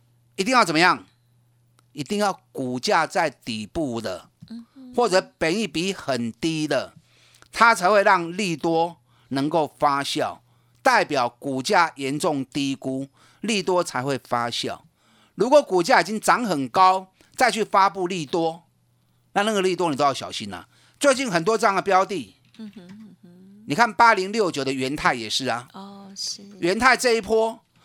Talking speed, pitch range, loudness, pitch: 220 characters per minute, 135-205 Hz, -22 LUFS, 175 Hz